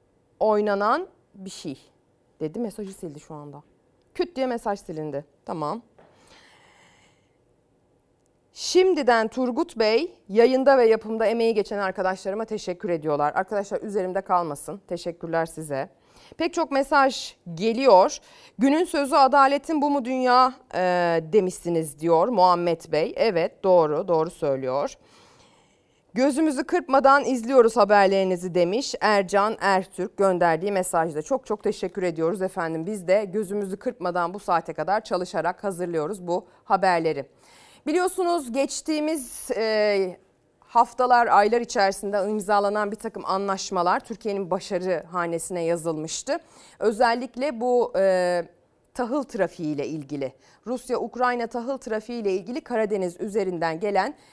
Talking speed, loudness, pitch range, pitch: 110 wpm, -23 LUFS, 175-245 Hz, 205 Hz